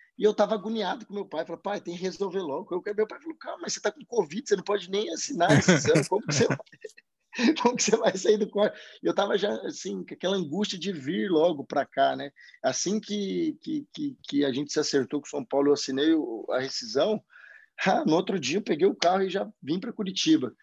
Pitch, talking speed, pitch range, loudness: 205 Hz, 235 wpm, 185-250 Hz, -27 LUFS